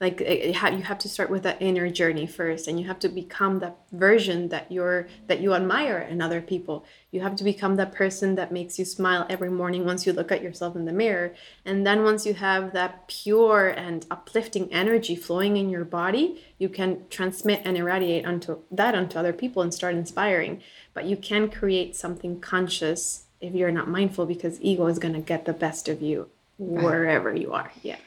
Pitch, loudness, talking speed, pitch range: 180 Hz, -25 LUFS, 205 wpm, 170-195 Hz